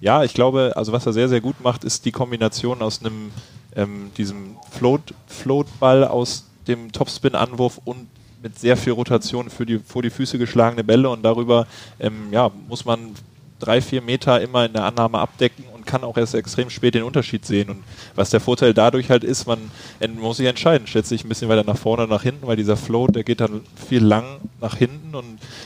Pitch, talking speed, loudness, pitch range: 120 Hz, 210 wpm, -20 LUFS, 110-125 Hz